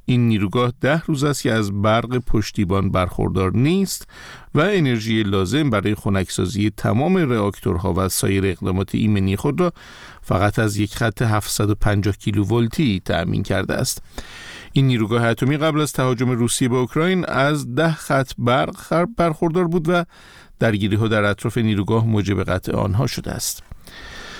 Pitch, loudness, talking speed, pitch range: 115 Hz, -20 LUFS, 150 wpm, 100-135 Hz